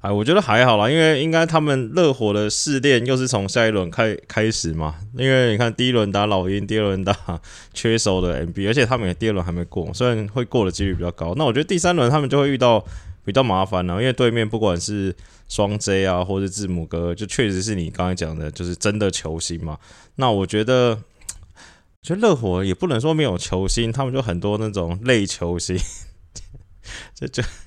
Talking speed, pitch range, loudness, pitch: 320 characters per minute, 90-120 Hz, -20 LUFS, 105 Hz